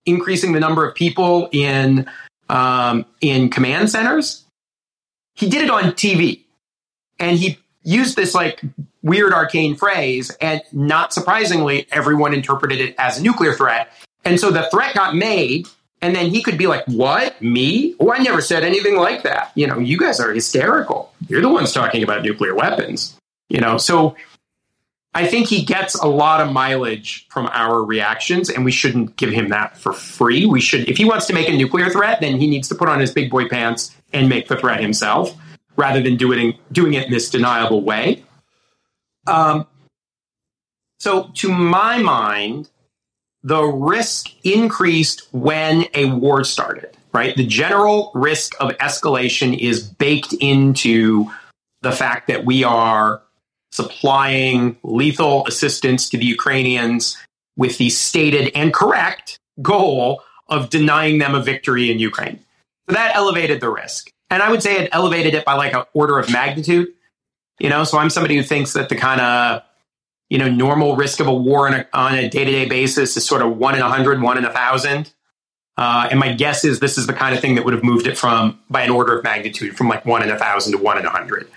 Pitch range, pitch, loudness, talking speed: 125-165 Hz, 140 Hz, -16 LUFS, 190 wpm